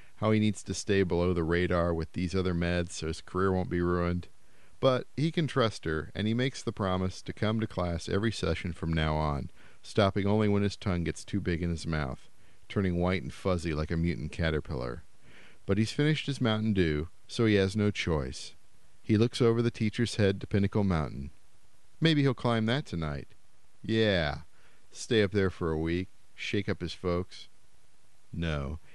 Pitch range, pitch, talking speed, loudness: 85-110 Hz, 95 Hz, 195 wpm, -30 LUFS